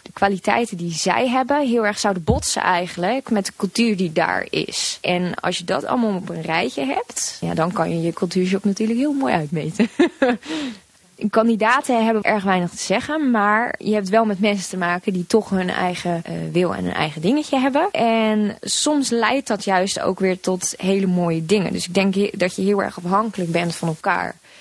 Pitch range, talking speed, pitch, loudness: 180-225 Hz, 200 wpm, 200 Hz, -20 LUFS